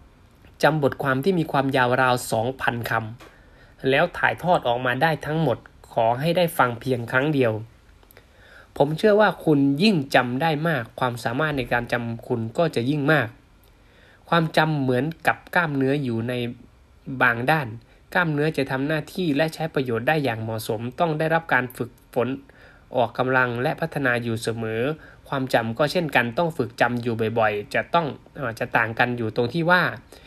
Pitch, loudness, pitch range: 130 Hz, -23 LUFS, 120-155 Hz